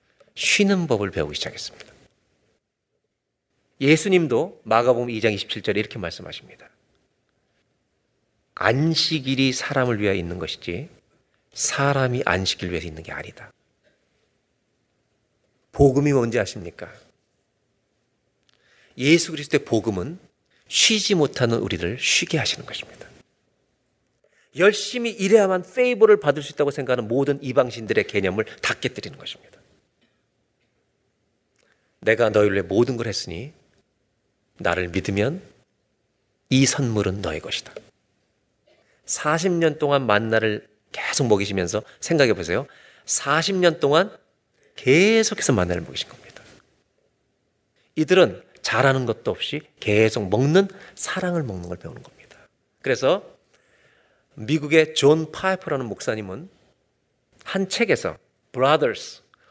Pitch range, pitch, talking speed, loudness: 105-165 Hz, 135 Hz, 255 characters per minute, -21 LUFS